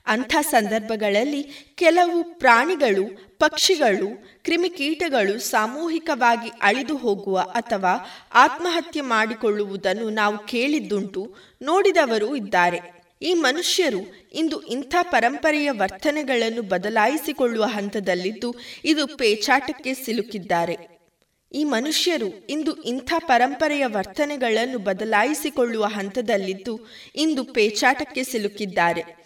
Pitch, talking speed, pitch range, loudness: 240 Hz, 80 wpm, 210-300 Hz, -22 LUFS